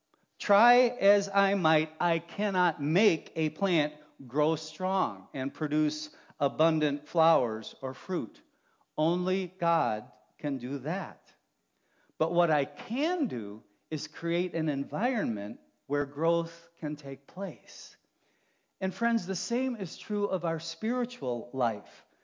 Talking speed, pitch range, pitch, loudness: 125 wpm, 145-190 Hz, 165 Hz, -30 LUFS